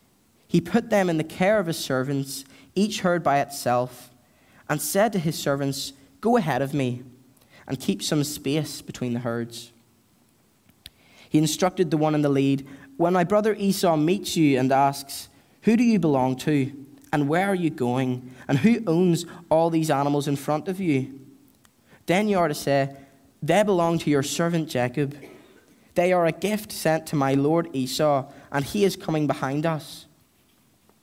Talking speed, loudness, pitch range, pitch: 175 wpm, -24 LUFS, 135-175 Hz, 150 Hz